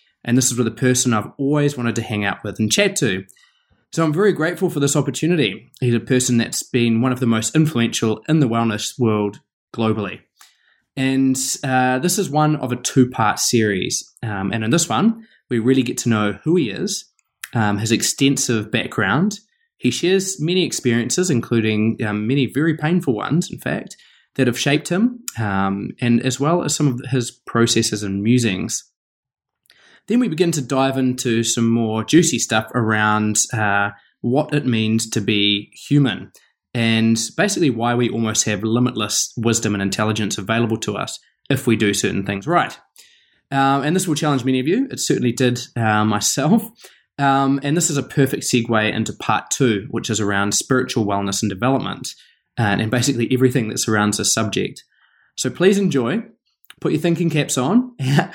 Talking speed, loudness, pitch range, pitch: 180 wpm, -19 LUFS, 110-145 Hz, 125 Hz